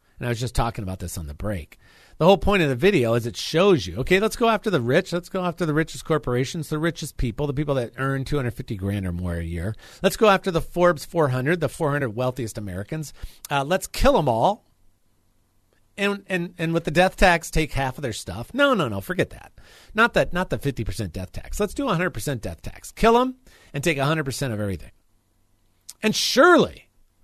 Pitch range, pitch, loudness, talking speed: 105-175 Hz, 135 Hz, -23 LUFS, 215 wpm